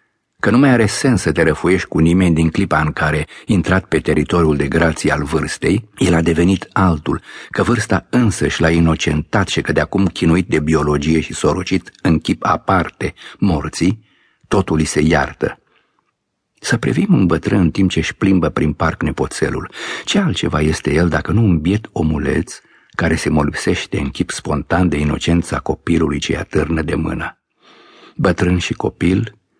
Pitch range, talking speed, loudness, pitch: 80-95 Hz, 170 wpm, -16 LUFS, 85 Hz